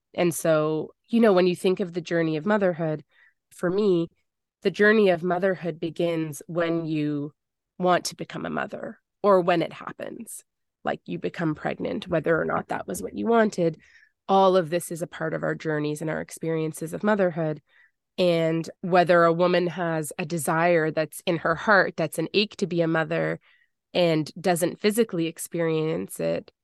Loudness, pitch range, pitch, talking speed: -25 LUFS, 160-185 Hz, 170 Hz, 180 wpm